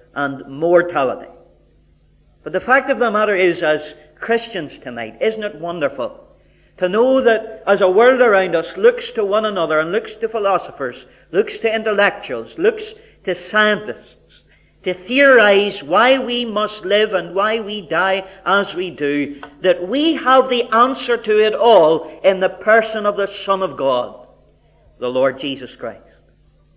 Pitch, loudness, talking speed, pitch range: 200 Hz, -16 LUFS, 155 wpm, 170-235 Hz